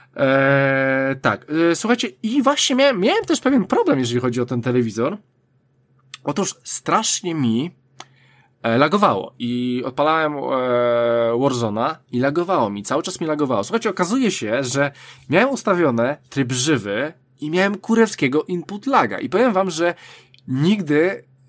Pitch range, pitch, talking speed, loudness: 125-185 Hz, 140 Hz, 140 wpm, -19 LUFS